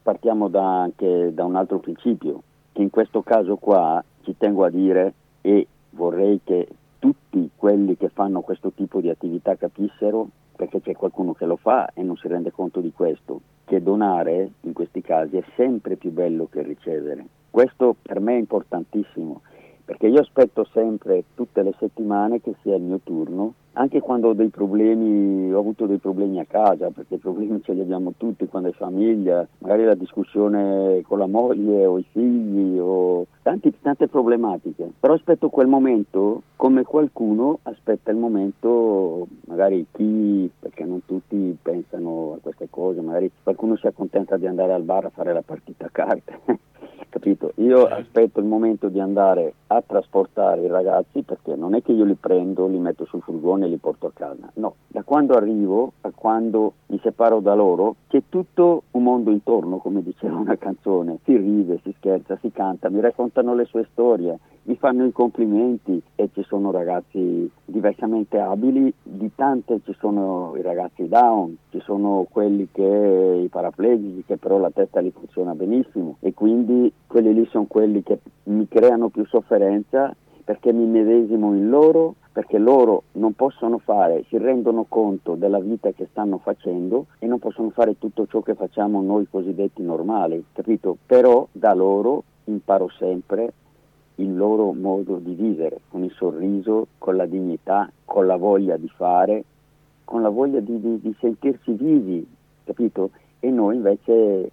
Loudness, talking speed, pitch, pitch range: -21 LUFS, 170 wpm, 105 Hz, 95-115 Hz